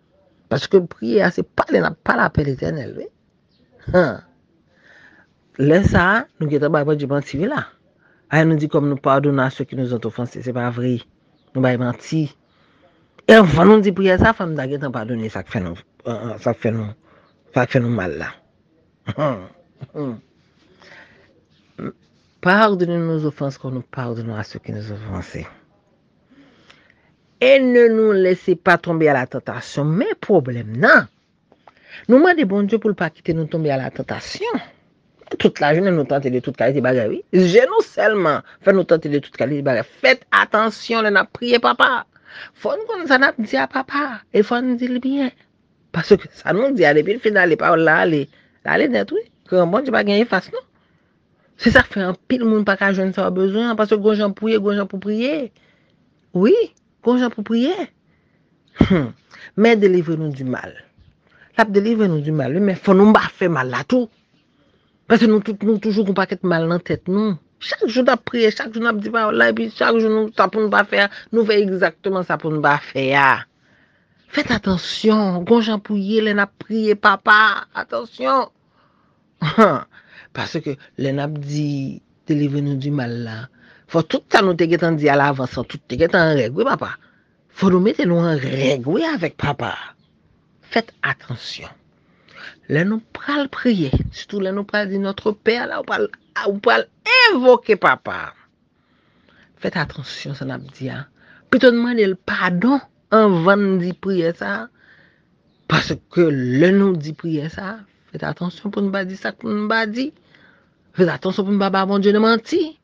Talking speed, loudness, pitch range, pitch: 185 wpm, -18 LUFS, 145-220 Hz, 185 Hz